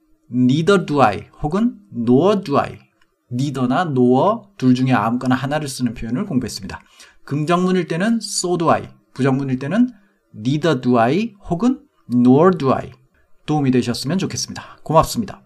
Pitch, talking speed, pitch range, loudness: 135 Hz, 395 characters per minute, 125-185 Hz, -18 LUFS